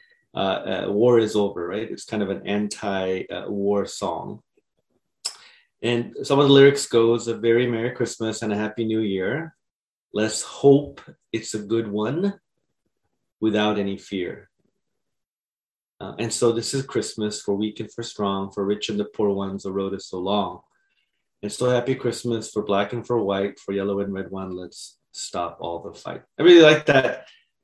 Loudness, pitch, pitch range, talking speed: -22 LUFS, 110 Hz, 100-120 Hz, 180 wpm